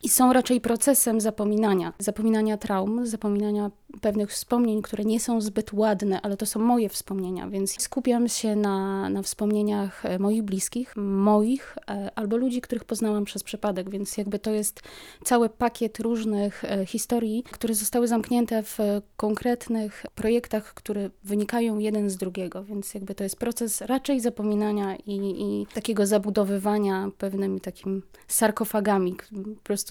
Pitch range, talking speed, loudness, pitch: 200-230 Hz, 140 wpm, -26 LUFS, 210 Hz